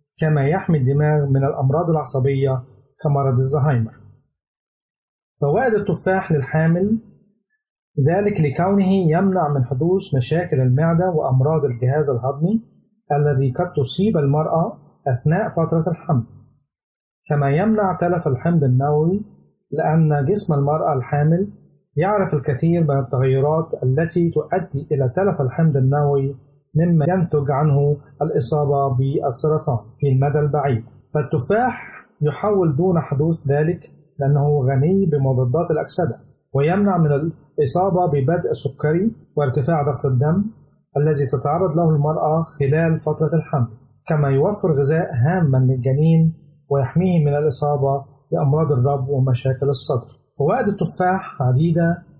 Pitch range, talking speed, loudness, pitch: 140-170 Hz, 110 wpm, -19 LUFS, 150 Hz